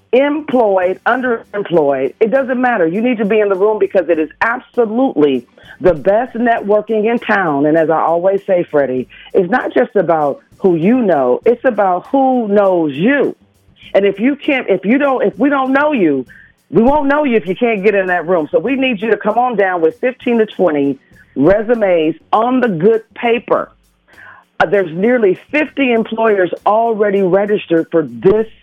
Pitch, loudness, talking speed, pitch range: 210 Hz, -14 LUFS, 185 wpm, 185-245 Hz